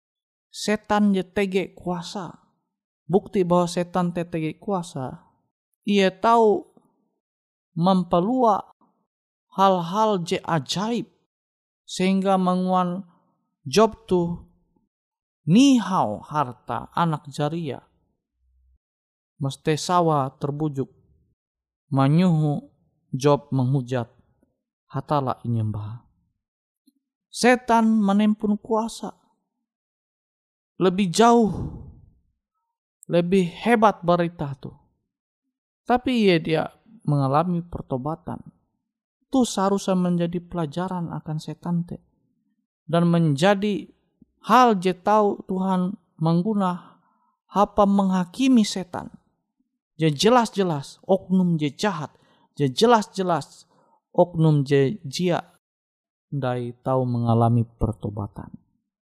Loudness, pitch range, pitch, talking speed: -22 LUFS, 150-210 Hz, 180 Hz, 75 wpm